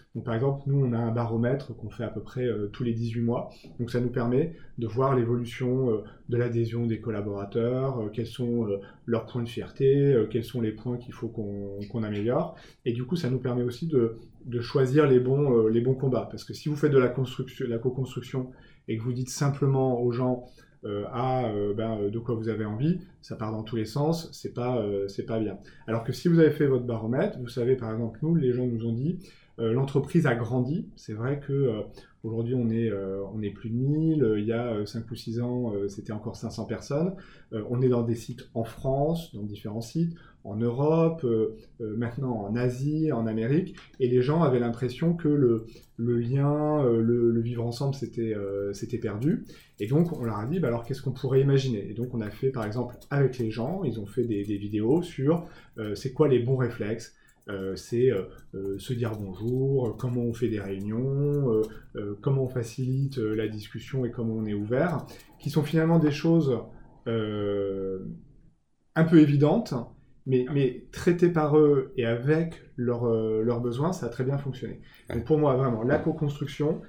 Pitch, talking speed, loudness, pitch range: 120 Hz, 210 wpm, -28 LUFS, 115-140 Hz